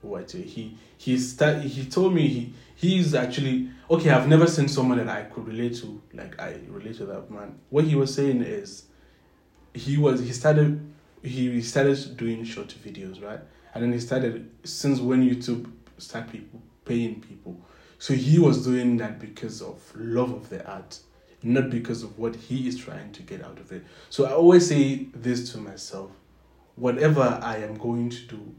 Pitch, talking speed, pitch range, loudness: 125 Hz, 185 wpm, 115-140 Hz, -24 LUFS